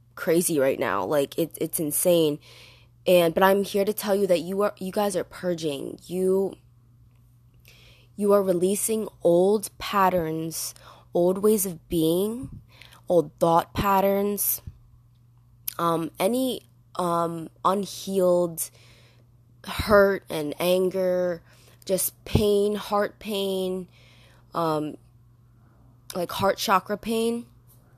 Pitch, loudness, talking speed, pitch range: 170 Hz, -24 LUFS, 105 wpm, 120-195 Hz